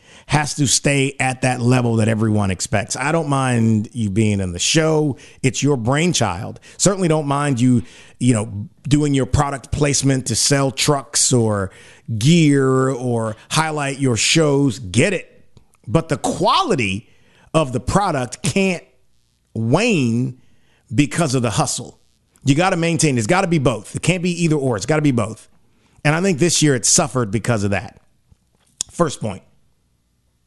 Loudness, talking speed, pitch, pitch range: -18 LUFS, 165 wpm, 130 Hz, 110-150 Hz